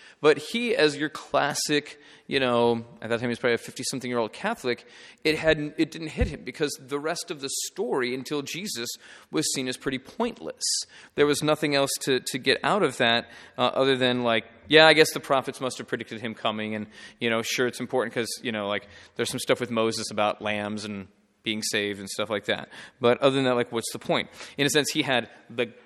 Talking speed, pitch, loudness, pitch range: 225 wpm, 125 Hz, -26 LUFS, 115-145 Hz